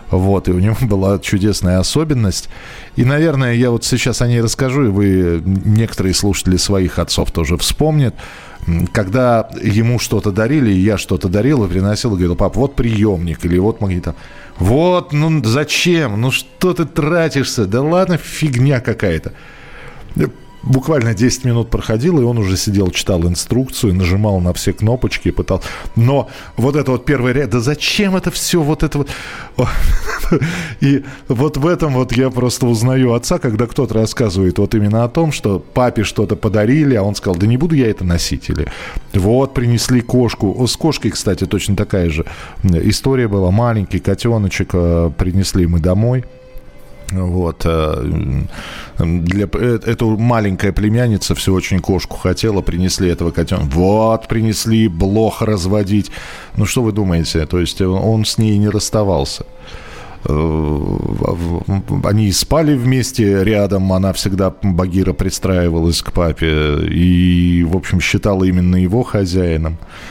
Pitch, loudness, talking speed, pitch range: 105 Hz, -15 LUFS, 145 wpm, 90-125 Hz